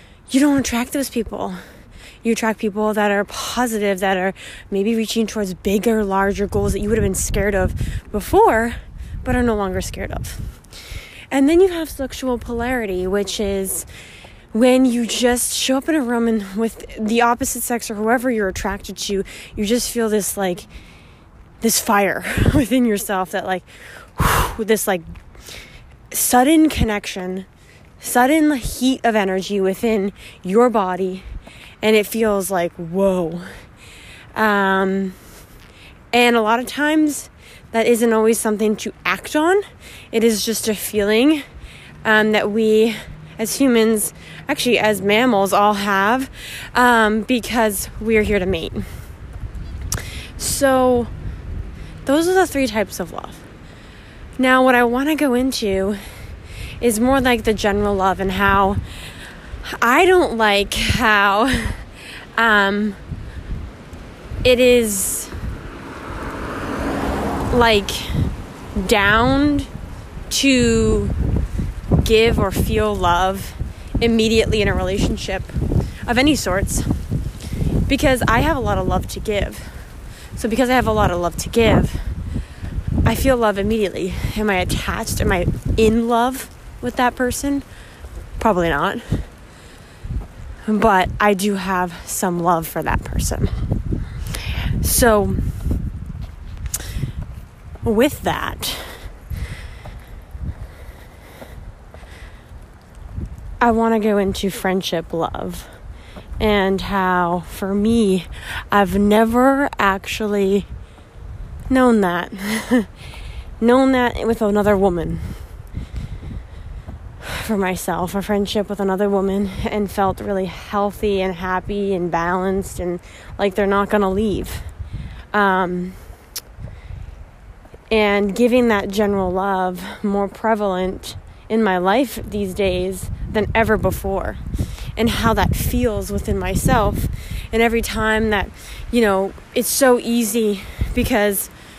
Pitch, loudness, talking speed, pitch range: 210 Hz, -18 LUFS, 120 wpm, 185-235 Hz